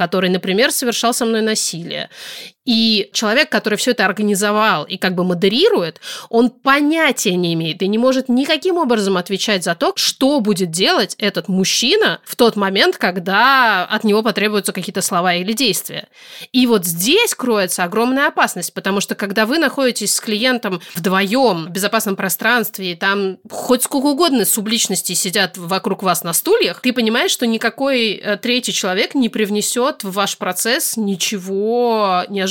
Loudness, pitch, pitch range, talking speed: -16 LUFS, 215 Hz, 190-245 Hz, 155 wpm